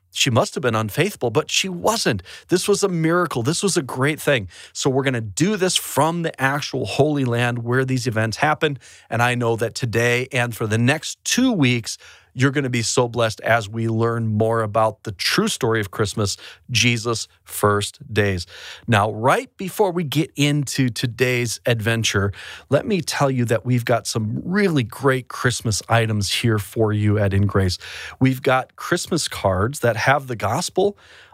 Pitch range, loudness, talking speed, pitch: 110-145 Hz, -20 LUFS, 185 wpm, 120 Hz